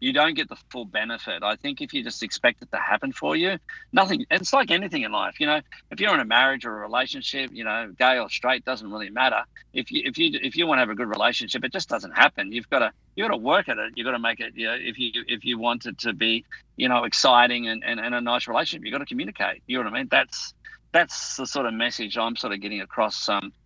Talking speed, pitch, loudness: 285 wpm, 120 Hz, -24 LUFS